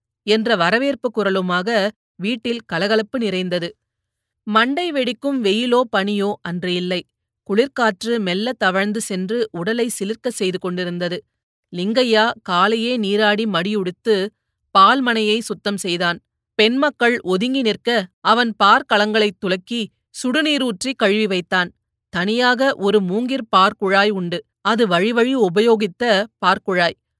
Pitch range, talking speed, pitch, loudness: 185-235 Hz, 100 wpm, 210 Hz, -18 LUFS